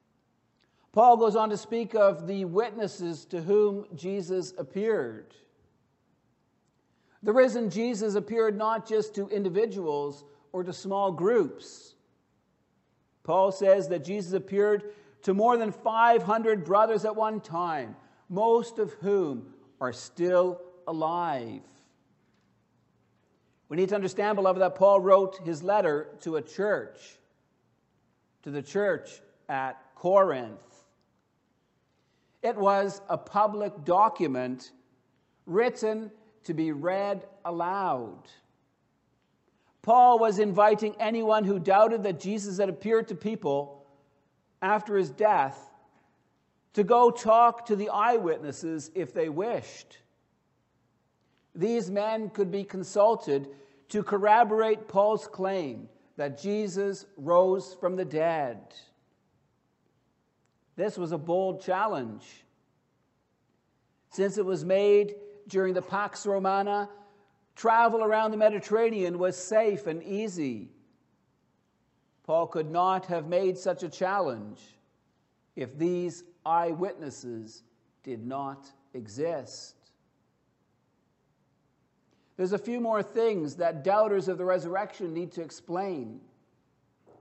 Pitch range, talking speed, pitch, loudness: 170-215 Hz, 110 wpm, 195 Hz, -27 LUFS